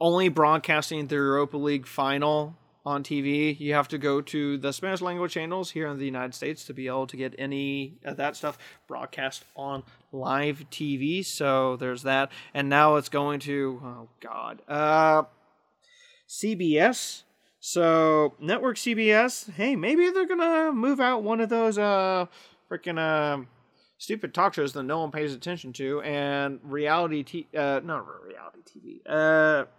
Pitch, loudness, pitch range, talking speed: 150 Hz, -26 LUFS, 140-175 Hz, 160 wpm